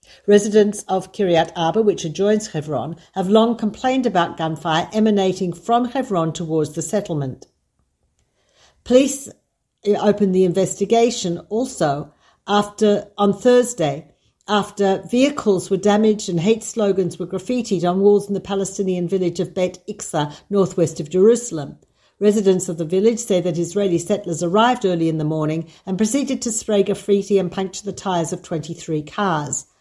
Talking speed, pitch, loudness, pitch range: 145 wpm, 195 Hz, -19 LUFS, 170-210 Hz